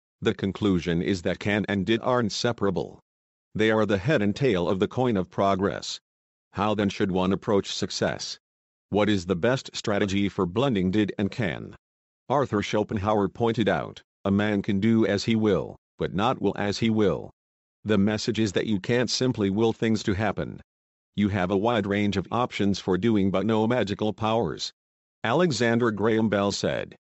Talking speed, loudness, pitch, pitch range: 180 wpm, -25 LUFS, 105 Hz, 95-110 Hz